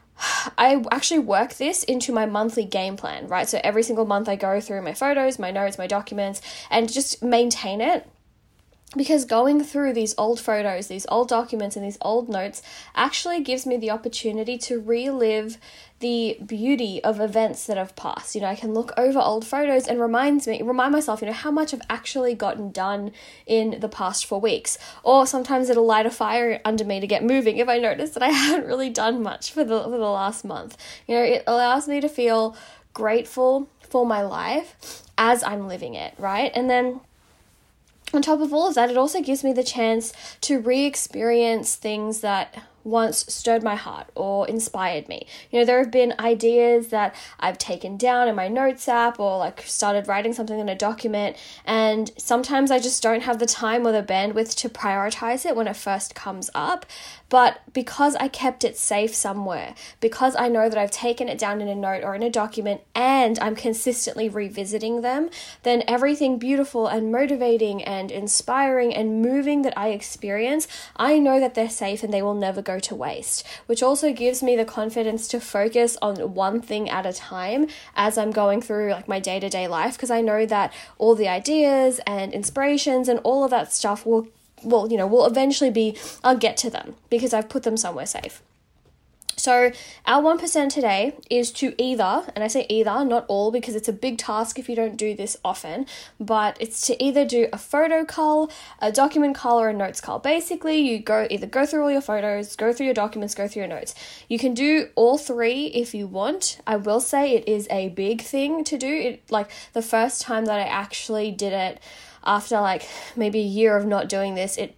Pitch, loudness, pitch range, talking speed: 230 Hz, -22 LUFS, 210-255 Hz, 205 wpm